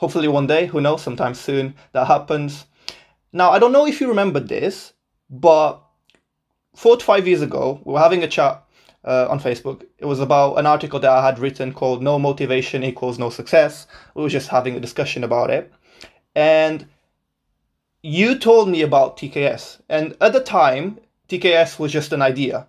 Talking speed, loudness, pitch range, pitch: 185 wpm, -18 LUFS, 130-160 Hz, 145 Hz